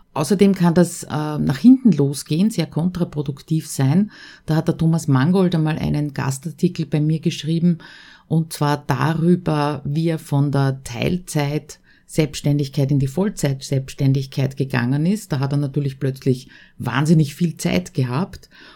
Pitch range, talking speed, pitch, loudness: 140-170 Hz, 140 wpm, 155 Hz, -20 LUFS